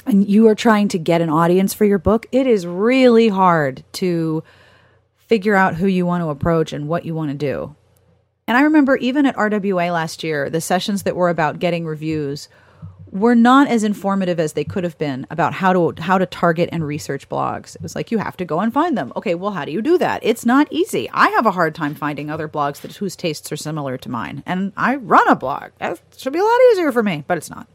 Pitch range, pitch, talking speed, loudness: 155-220 Hz, 180 Hz, 245 wpm, -18 LUFS